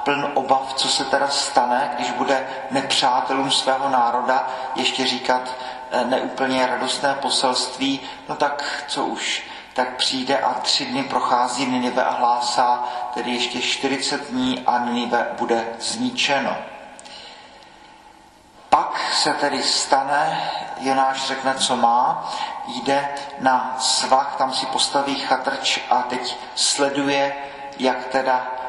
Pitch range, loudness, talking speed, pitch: 125-140 Hz, -21 LUFS, 120 wpm, 130 Hz